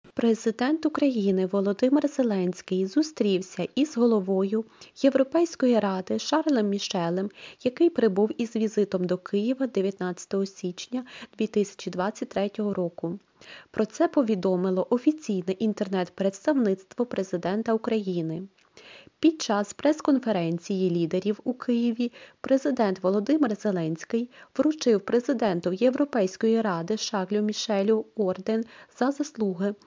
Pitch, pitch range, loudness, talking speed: 215 Hz, 190-250 Hz, -26 LUFS, 90 wpm